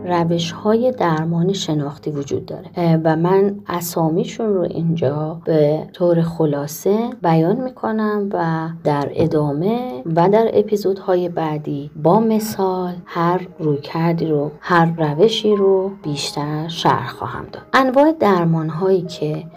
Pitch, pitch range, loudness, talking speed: 170 Hz, 155-195 Hz, -18 LUFS, 125 wpm